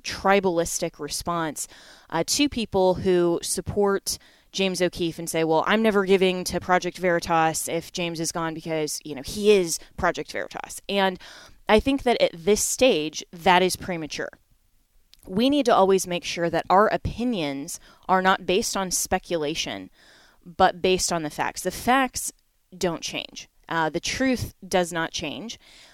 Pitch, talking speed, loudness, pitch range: 180 Hz, 155 wpm, -24 LUFS, 165-195 Hz